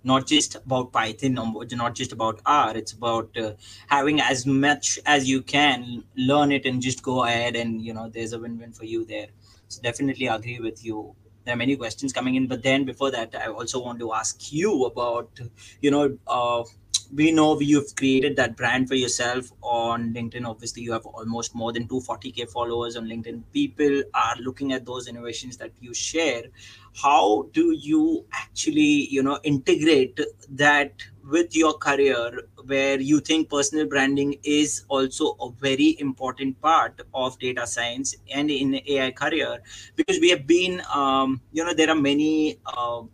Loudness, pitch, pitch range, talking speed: -23 LUFS, 130 Hz, 115-145 Hz, 175 wpm